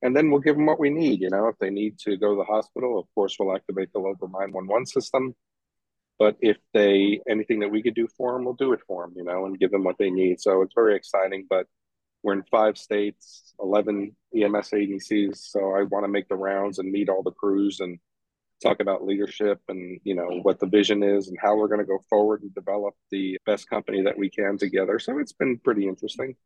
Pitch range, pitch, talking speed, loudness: 95-105 Hz, 100 Hz, 240 wpm, -24 LUFS